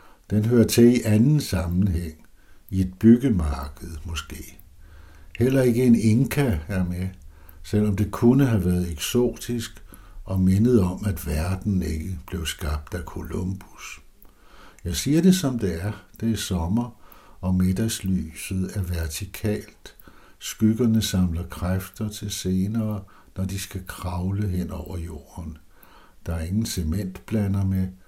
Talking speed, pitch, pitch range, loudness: 130 wpm, 95 Hz, 90-110 Hz, -24 LUFS